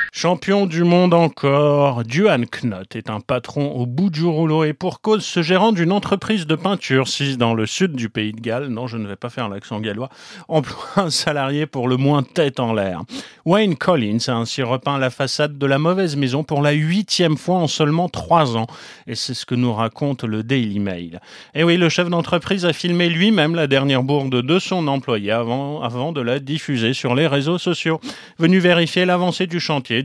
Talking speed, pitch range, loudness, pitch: 205 wpm, 125-175 Hz, -19 LUFS, 145 Hz